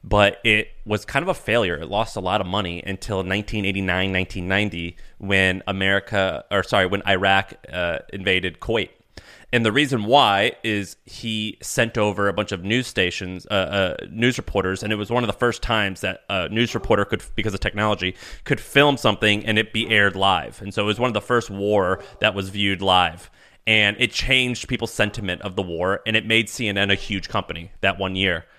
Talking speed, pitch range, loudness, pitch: 205 wpm, 95-110 Hz, -21 LUFS, 105 Hz